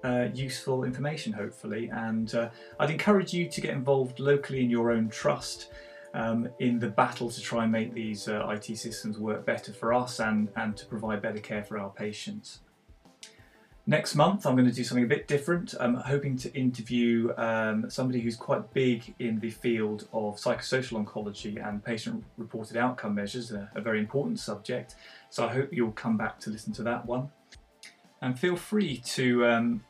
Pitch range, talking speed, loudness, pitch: 110-130 Hz, 185 wpm, -30 LUFS, 120 Hz